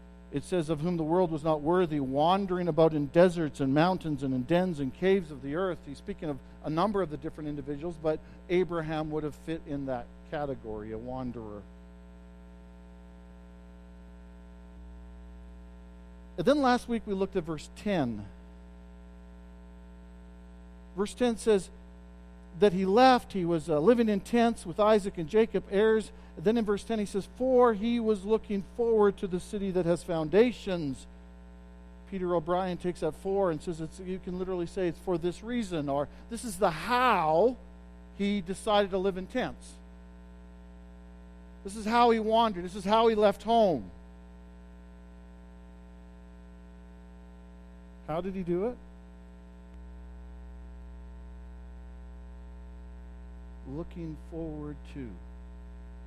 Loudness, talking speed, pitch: -29 LUFS, 140 wpm, 145 Hz